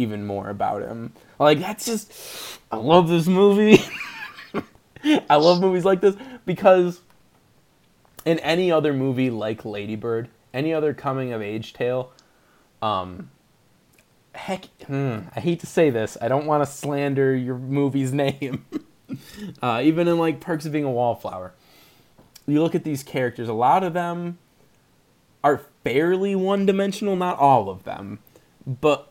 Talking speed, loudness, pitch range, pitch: 145 wpm, -22 LUFS, 125-175 Hz, 145 Hz